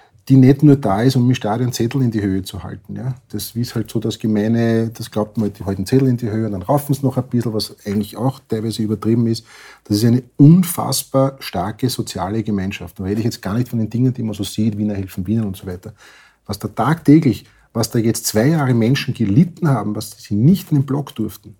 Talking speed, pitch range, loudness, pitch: 240 wpm, 105-130 Hz, -18 LUFS, 115 Hz